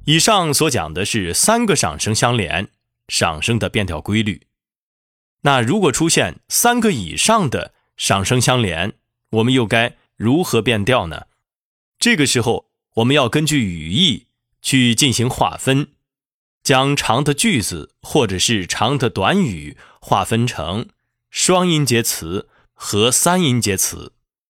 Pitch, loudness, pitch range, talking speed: 120 Hz, -17 LUFS, 110-140 Hz, 200 characters per minute